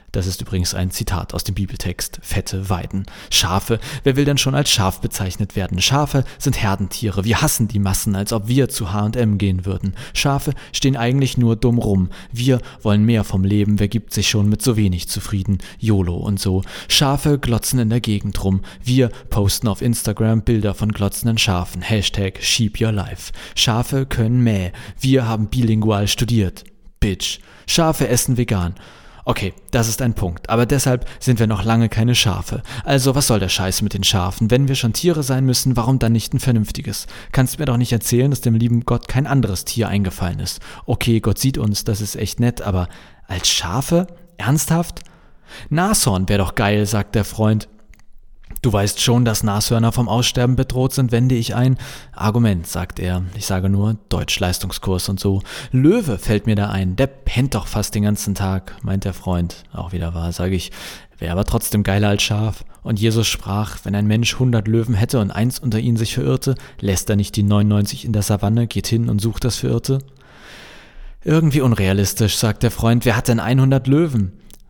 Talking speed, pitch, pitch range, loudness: 190 wpm, 110 Hz, 100-125 Hz, -18 LUFS